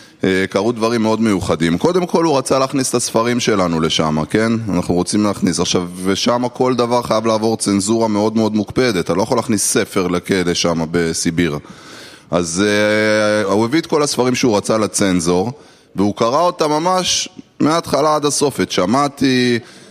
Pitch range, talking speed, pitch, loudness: 95-125 Hz, 160 wpm, 110 Hz, -16 LUFS